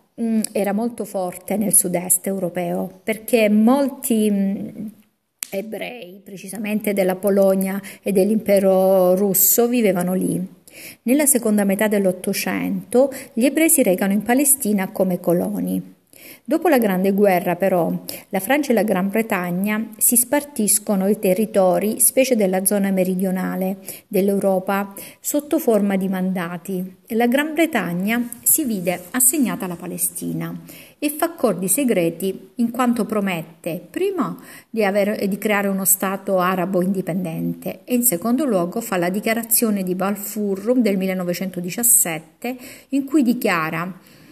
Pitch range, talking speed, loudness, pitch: 185-235 Hz, 125 wpm, -19 LUFS, 200 Hz